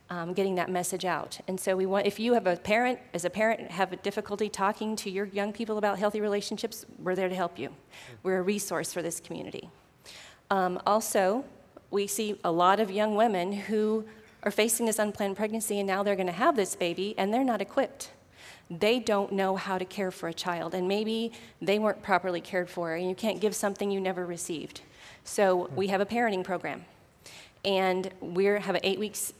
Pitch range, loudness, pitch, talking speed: 185-215 Hz, -29 LUFS, 195 Hz, 210 wpm